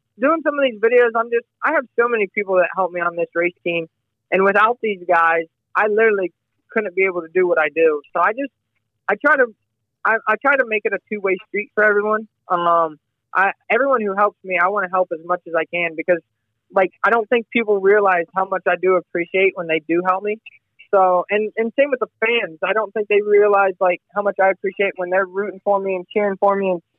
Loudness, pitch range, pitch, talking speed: -18 LUFS, 175-215 Hz, 195 Hz, 235 wpm